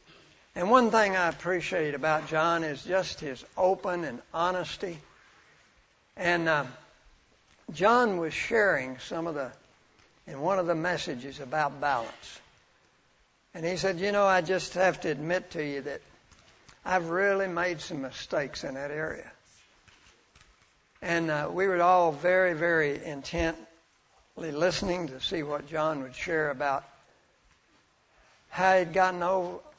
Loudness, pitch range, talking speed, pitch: -28 LUFS, 150-185 Hz, 140 wpm, 170 Hz